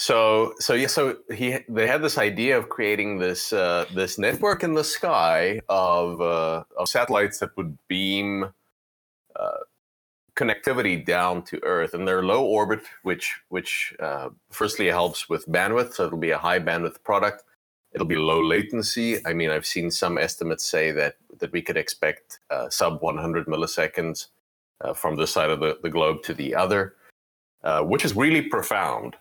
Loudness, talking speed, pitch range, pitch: -24 LUFS, 170 wpm, 80-110 Hz, 95 Hz